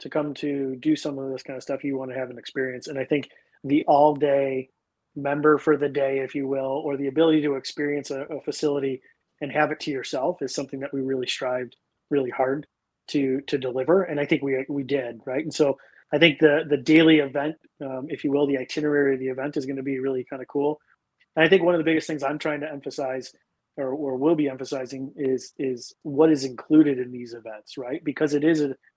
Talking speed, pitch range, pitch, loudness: 235 wpm, 130-150 Hz, 140 Hz, -24 LUFS